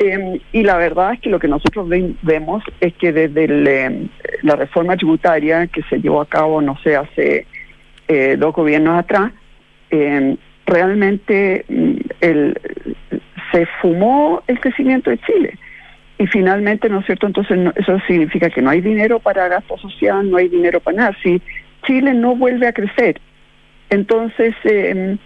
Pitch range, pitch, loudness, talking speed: 165-215 Hz, 190 Hz, -15 LUFS, 155 wpm